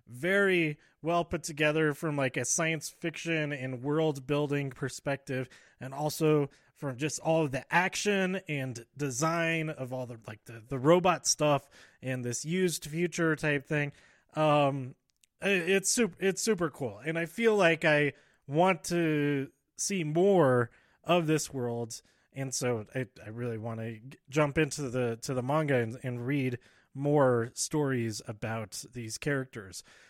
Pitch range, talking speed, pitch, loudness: 130-165 Hz, 155 wpm, 145 Hz, -30 LUFS